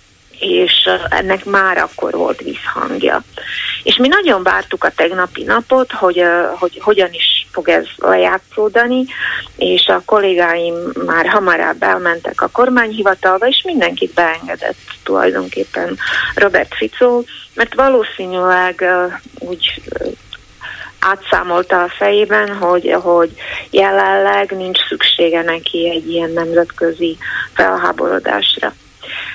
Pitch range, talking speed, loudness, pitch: 170-215 Hz, 105 wpm, -13 LUFS, 185 Hz